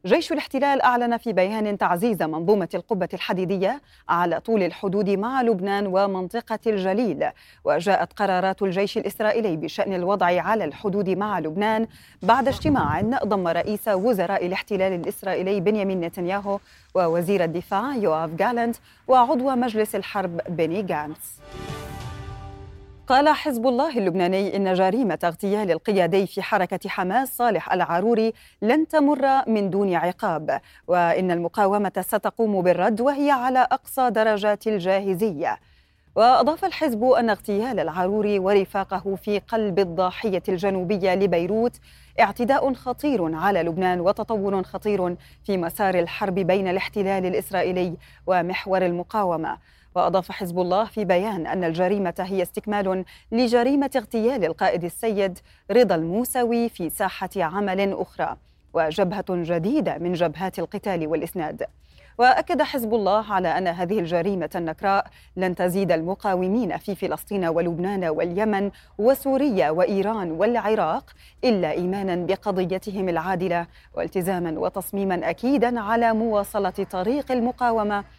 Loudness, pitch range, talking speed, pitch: -23 LUFS, 180-220 Hz, 115 wpm, 195 Hz